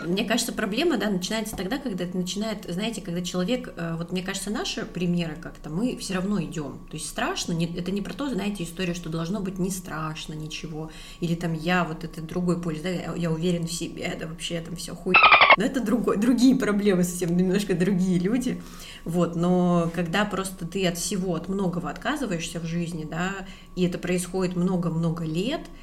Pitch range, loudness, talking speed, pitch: 170-200 Hz, -25 LUFS, 195 wpm, 180 Hz